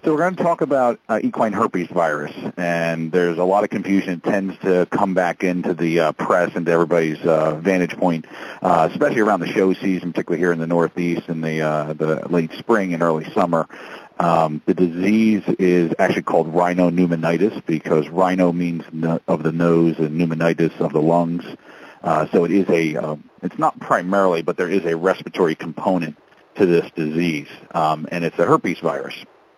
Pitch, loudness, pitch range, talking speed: 85 Hz, -19 LUFS, 80-90 Hz, 190 wpm